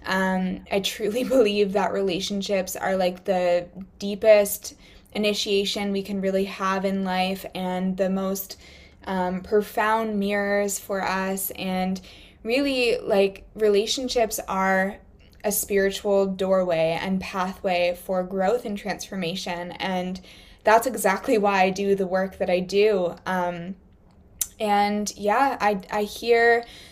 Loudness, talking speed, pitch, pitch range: -24 LUFS, 125 wpm, 195 Hz, 185-205 Hz